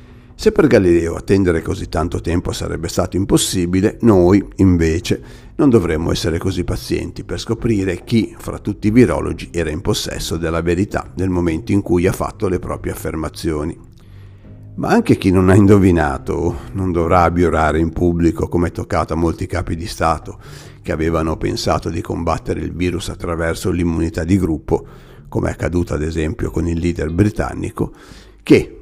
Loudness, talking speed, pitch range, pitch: -17 LUFS, 160 wpm, 85-100 Hz, 90 Hz